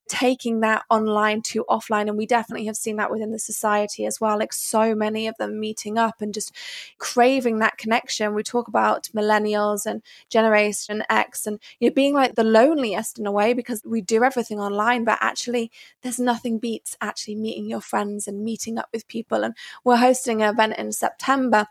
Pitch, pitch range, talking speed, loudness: 220 Hz, 210-240 Hz, 195 wpm, -22 LUFS